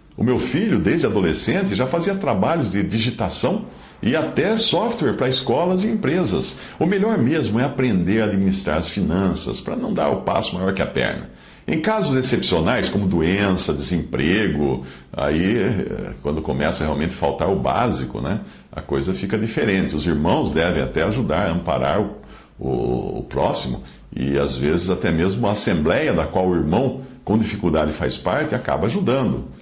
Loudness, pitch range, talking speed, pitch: -20 LUFS, 80-130 Hz, 165 wpm, 95 Hz